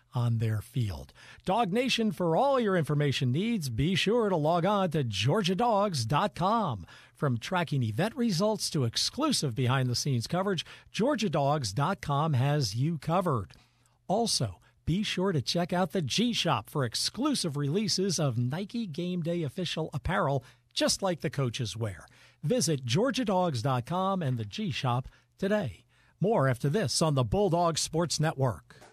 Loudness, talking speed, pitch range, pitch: -29 LUFS, 145 wpm, 130-195 Hz, 160 Hz